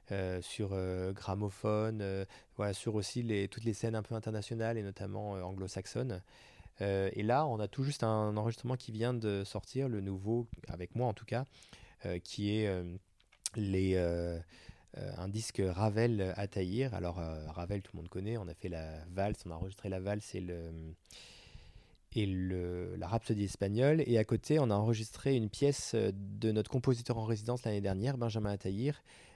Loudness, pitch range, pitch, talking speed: -36 LUFS, 95-115 Hz, 105 Hz, 190 wpm